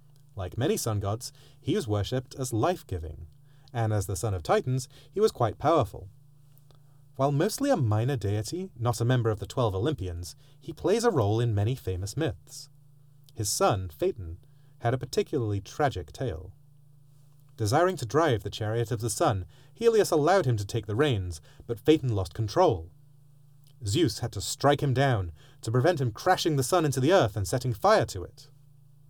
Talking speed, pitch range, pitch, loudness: 180 wpm, 110-145 Hz, 130 Hz, -27 LUFS